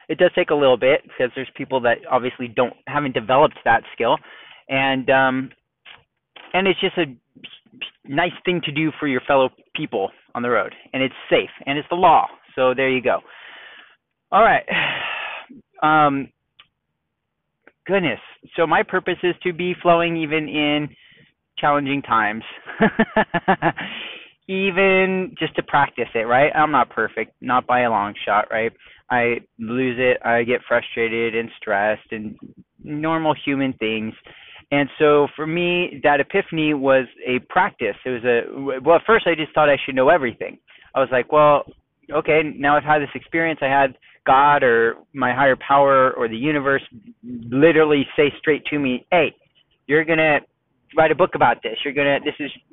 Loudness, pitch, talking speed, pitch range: -19 LUFS, 145 Hz, 165 wpm, 130-160 Hz